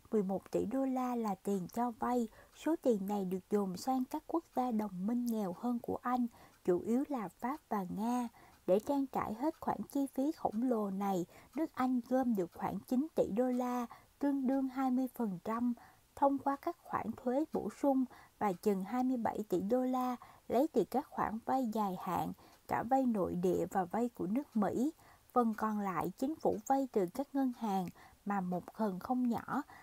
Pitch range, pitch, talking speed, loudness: 205-260 Hz, 245 Hz, 190 wpm, -36 LUFS